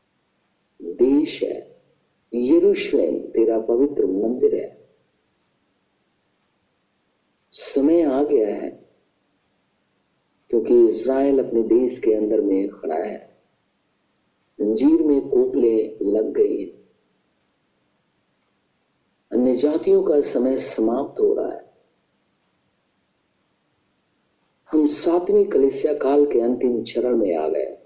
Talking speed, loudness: 95 wpm, -20 LUFS